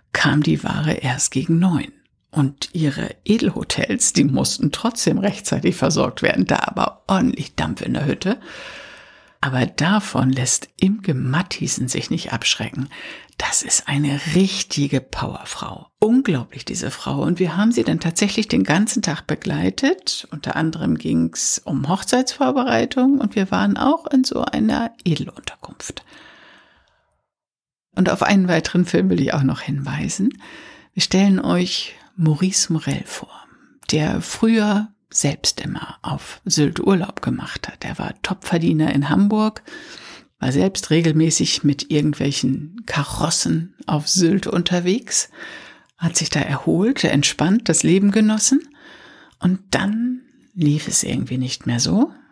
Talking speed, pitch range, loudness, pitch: 135 wpm, 150-215 Hz, -19 LUFS, 185 Hz